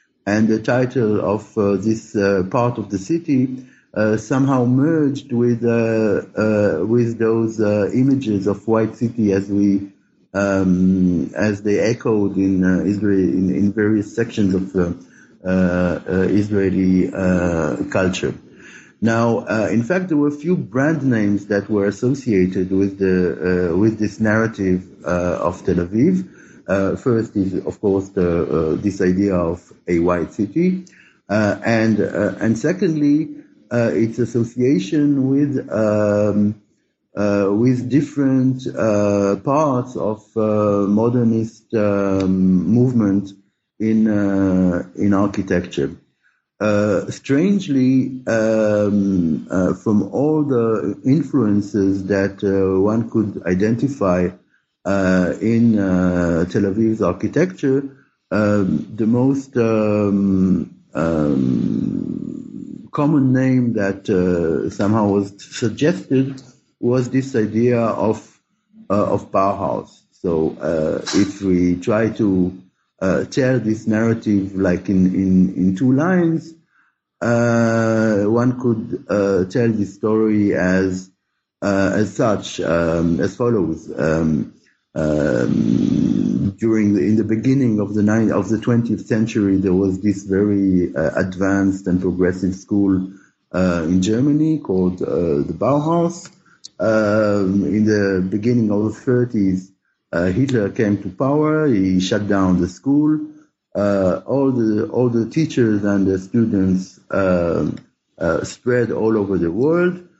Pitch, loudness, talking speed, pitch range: 105 Hz, -18 LUFS, 130 wpm, 95-120 Hz